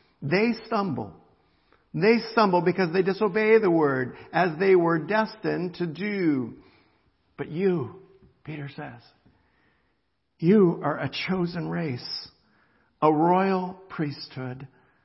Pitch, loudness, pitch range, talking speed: 170 Hz, -24 LUFS, 140-190 Hz, 110 wpm